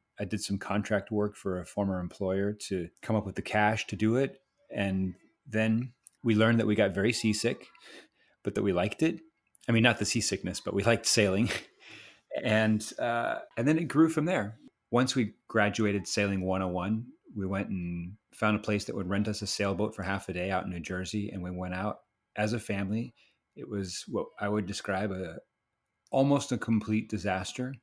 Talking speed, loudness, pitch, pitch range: 205 wpm, -30 LUFS, 105 Hz, 95-115 Hz